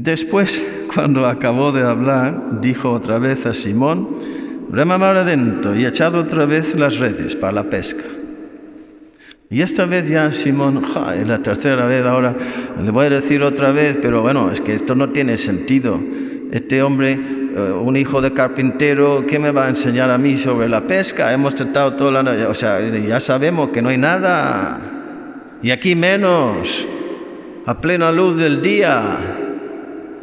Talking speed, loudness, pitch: 165 wpm, -16 LUFS, 145 Hz